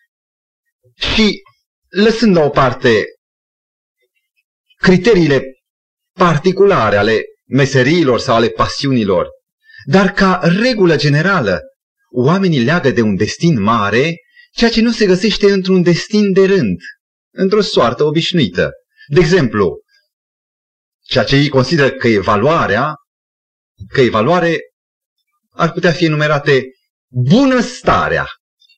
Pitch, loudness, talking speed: 190 Hz, -13 LUFS, 105 wpm